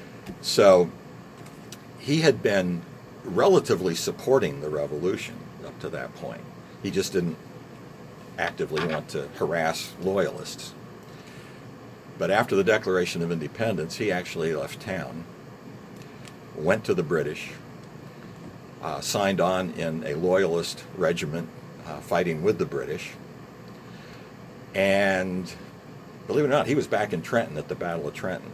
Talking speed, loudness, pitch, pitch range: 130 wpm, -26 LUFS, 90 Hz, 85-95 Hz